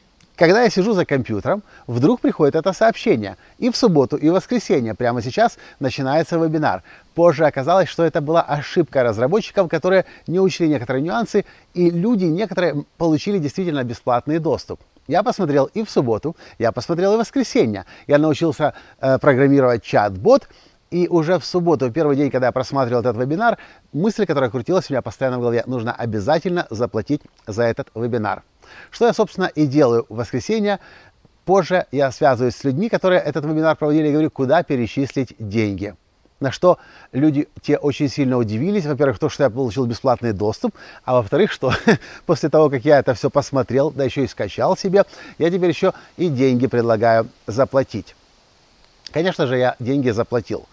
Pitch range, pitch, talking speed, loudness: 125-175 Hz, 145 Hz, 165 wpm, -19 LUFS